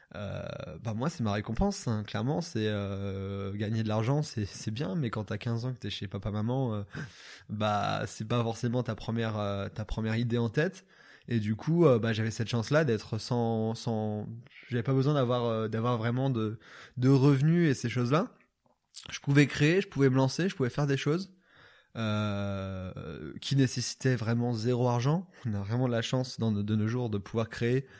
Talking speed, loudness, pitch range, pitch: 205 wpm, -30 LUFS, 110-135 Hz, 115 Hz